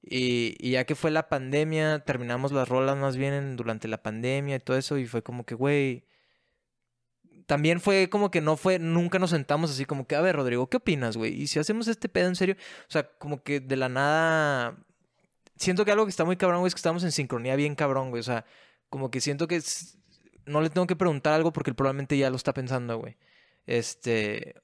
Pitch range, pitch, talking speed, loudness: 130-165 Hz, 145 Hz, 225 wpm, -27 LUFS